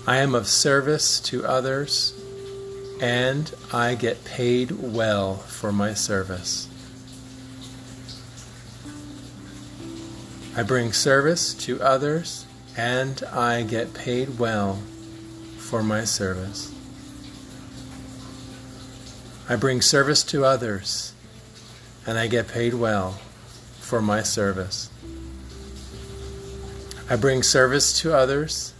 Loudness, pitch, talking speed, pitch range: -22 LUFS, 125 Hz, 95 wpm, 110-130 Hz